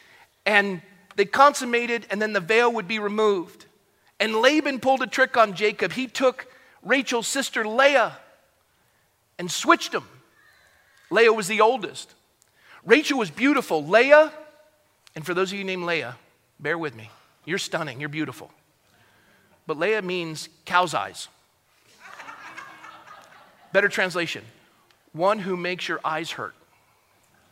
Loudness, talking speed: -22 LUFS, 130 wpm